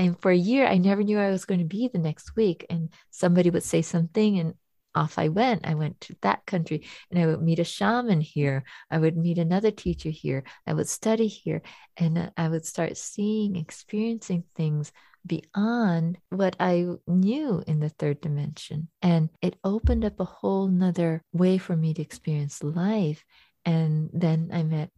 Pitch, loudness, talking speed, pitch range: 170 Hz, -26 LUFS, 190 wpm, 160-195 Hz